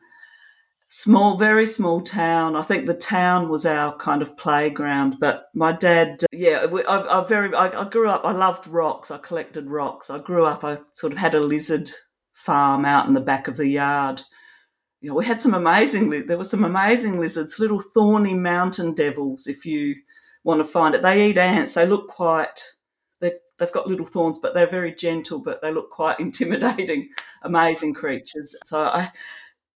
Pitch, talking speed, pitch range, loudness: 170 Hz, 190 wpm, 150-205 Hz, -21 LUFS